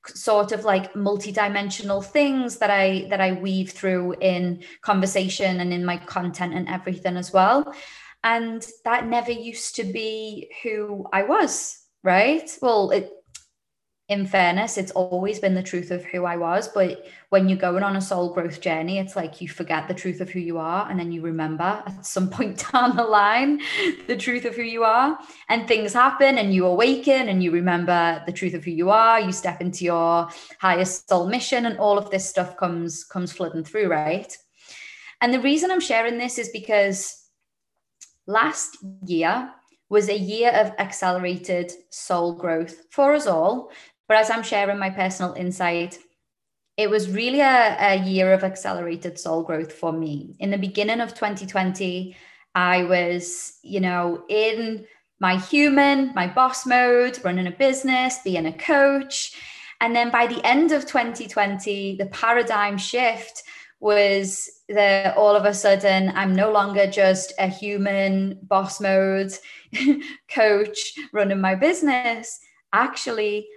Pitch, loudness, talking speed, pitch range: 200 Hz, -22 LUFS, 165 wpm, 185-230 Hz